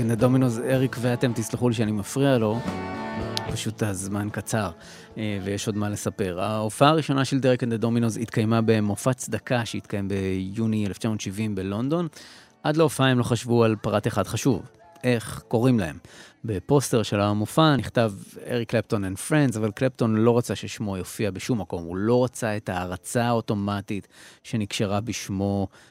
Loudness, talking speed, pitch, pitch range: -25 LUFS, 155 wpm, 115 Hz, 105-125 Hz